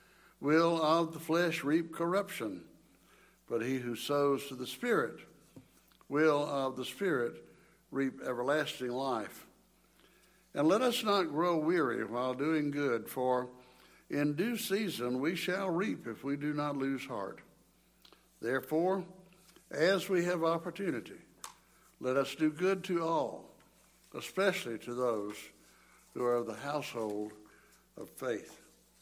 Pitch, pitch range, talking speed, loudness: 145 Hz, 130-175 Hz, 130 wpm, -34 LUFS